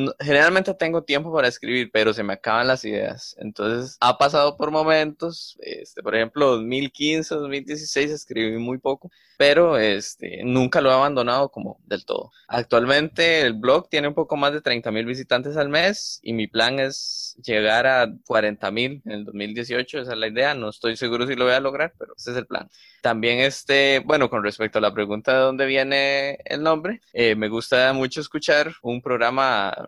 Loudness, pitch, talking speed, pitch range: -21 LUFS, 130 Hz, 190 wpm, 115-150 Hz